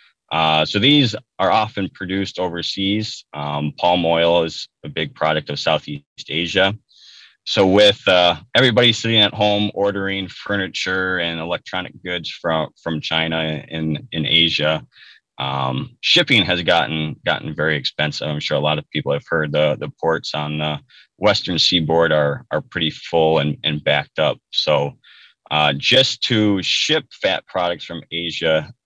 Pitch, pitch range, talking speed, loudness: 85 Hz, 75-100 Hz, 155 wpm, -18 LUFS